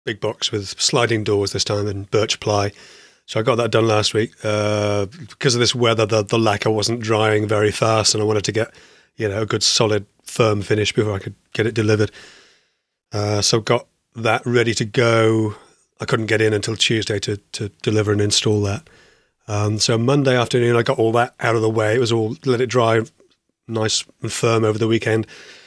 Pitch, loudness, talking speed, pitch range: 110 Hz, -19 LUFS, 210 wpm, 105-115 Hz